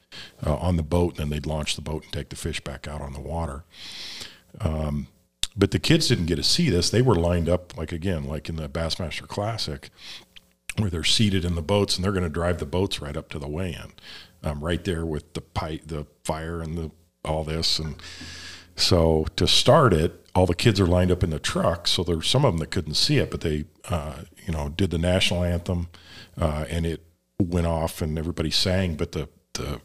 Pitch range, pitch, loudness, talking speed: 80-90 Hz, 85 Hz, -25 LUFS, 225 wpm